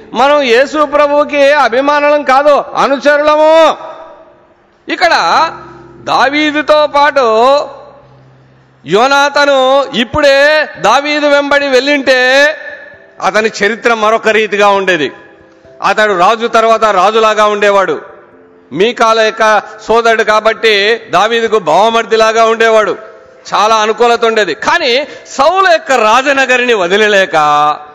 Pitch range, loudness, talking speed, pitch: 220-290 Hz, -9 LUFS, 85 wpm, 245 Hz